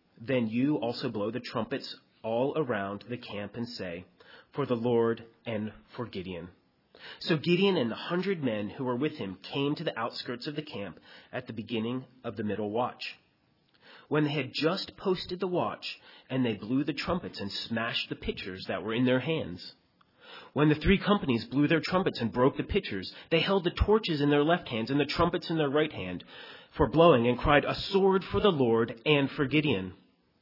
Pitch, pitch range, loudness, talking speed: 135 Hz, 115-160 Hz, -29 LUFS, 200 wpm